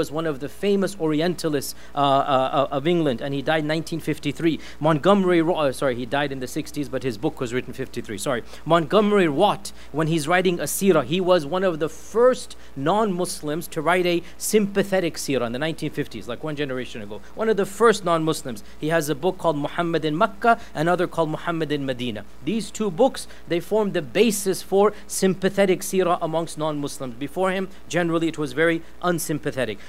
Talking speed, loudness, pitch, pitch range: 190 wpm, -23 LUFS, 165 Hz, 145-185 Hz